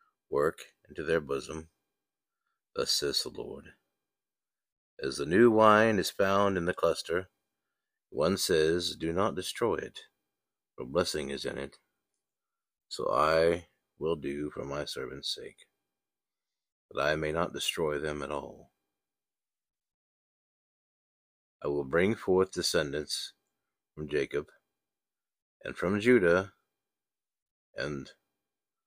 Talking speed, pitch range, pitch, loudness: 115 wpm, 75-95 Hz, 85 Hz, -30 LUFS